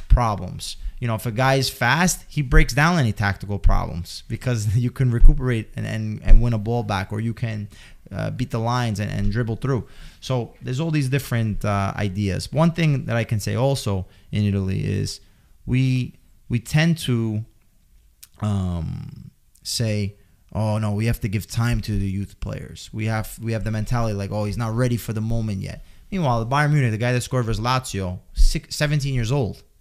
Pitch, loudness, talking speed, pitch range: 115 Hz, -23 LUFS, 200 wpm, 105-125 Hz